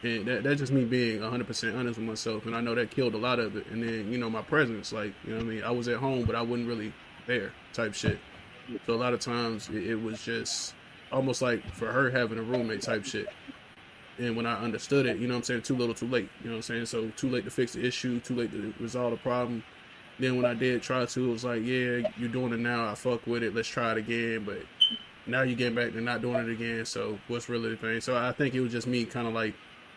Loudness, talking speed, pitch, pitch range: -31 LUFS, 275 wpm, 120 Hz, 115-125 Hz